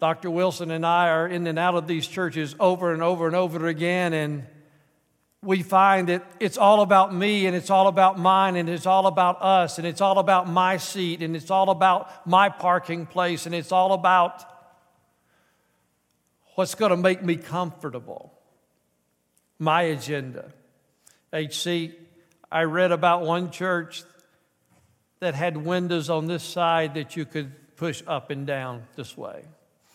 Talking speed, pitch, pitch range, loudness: 160 wpm, 175 Hz, 160-185 Hz, -23 LUFS